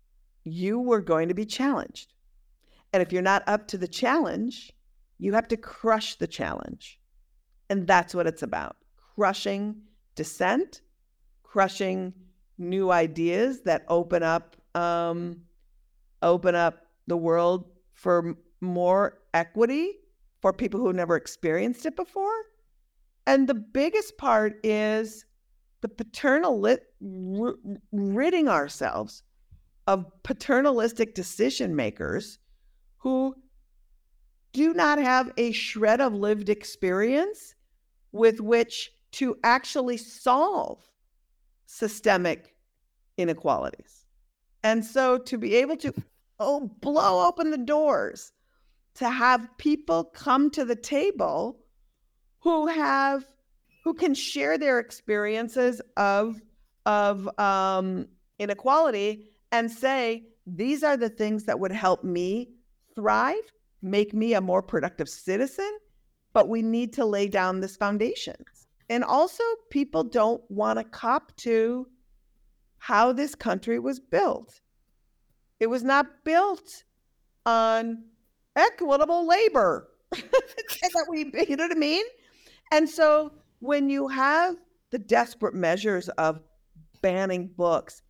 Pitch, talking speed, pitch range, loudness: 230 Hz, 115 wpm, 190-280 Hz, -26 LUFS